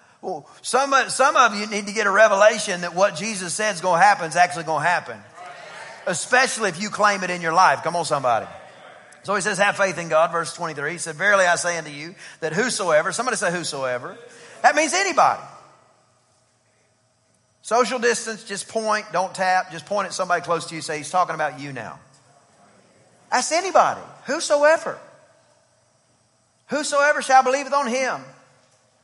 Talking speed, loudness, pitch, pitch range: 180 wpm, -20 LUFS, 185 Hz, 160-230 Hz